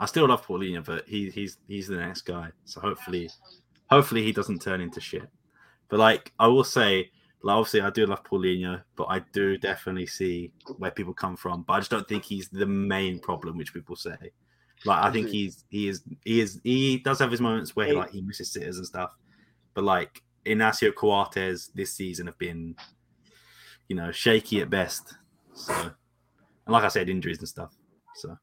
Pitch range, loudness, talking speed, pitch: 90-105 Hz, -27 LUFS, 200 wpm, 95 Hz